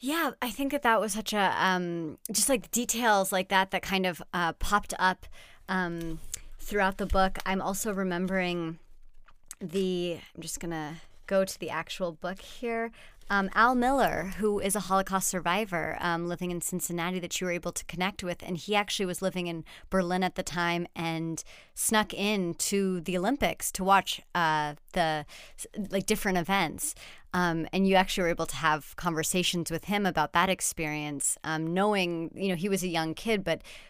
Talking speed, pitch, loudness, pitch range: 180 wpm, 185 Hz, -29 LUFS, 170-195 Hz